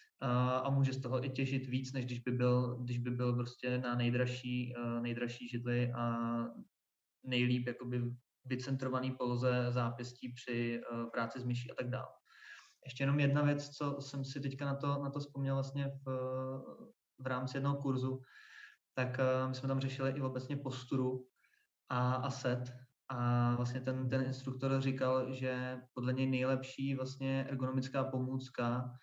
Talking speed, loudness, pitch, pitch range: 155 wpm, -37 LUFS, 130 Hz, 125-135 Hz